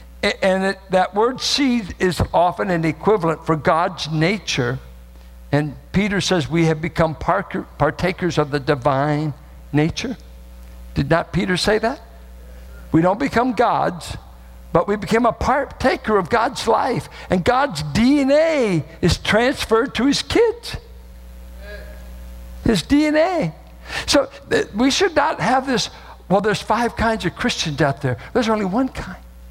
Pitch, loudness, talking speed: 180 Hz, -19 LUFS, 140 wpm